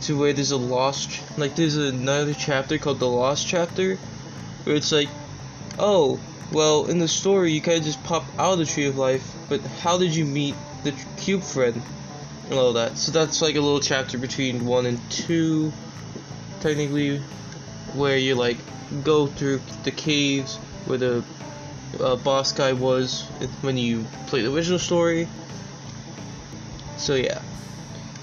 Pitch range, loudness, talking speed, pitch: 130-155 Hz, -23 LUFS, 160 wpm, 145 Hz